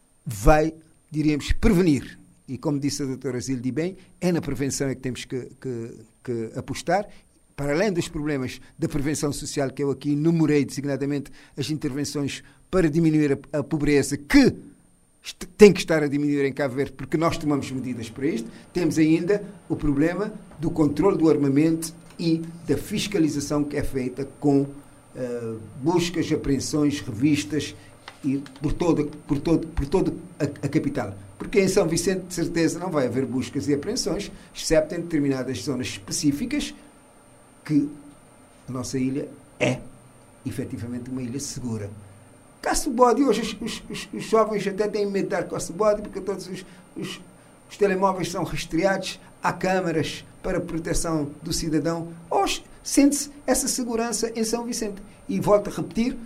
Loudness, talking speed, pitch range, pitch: -24 LUFS, 155 wpm, 140-180 Hz, 150 Hz